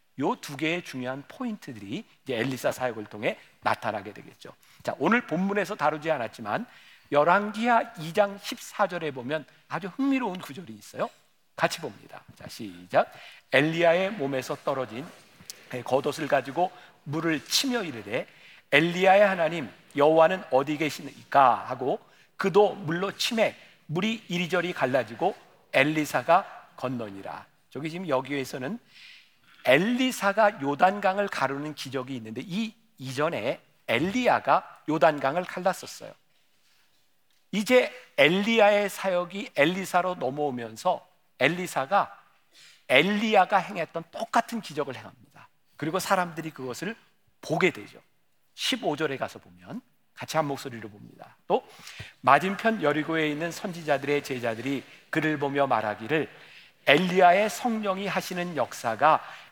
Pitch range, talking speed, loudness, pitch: 140-195 Hz, 290 characters per minute, -26 LUFS, 160 Hz